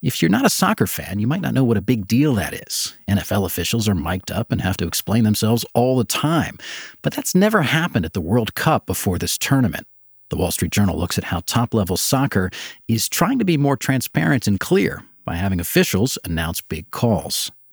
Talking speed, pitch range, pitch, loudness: 215 wpm, 95-130 Hz, 110 Hz, -20 LUFS